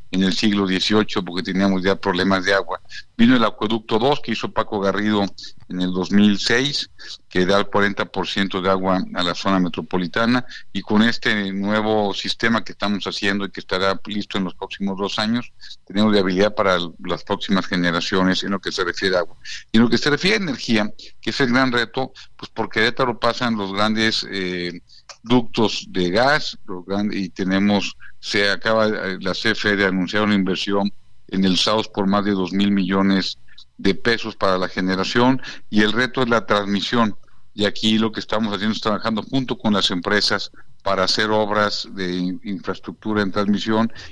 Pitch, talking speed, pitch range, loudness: 100 Hz, 180 wpm, 95-110 Hz, -20 LUFS